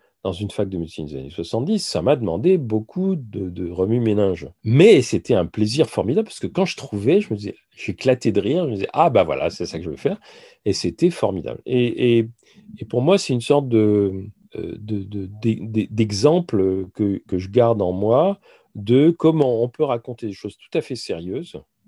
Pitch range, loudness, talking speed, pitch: 100-155 Hz, -20 LUFS, 215 wpm, 115 Hz